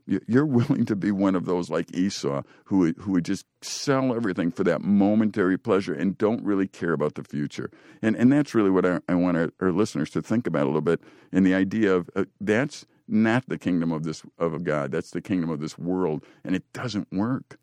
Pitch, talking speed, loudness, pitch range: 95 Hz, 230 wpm, -25 LUFS, 85-110 Hz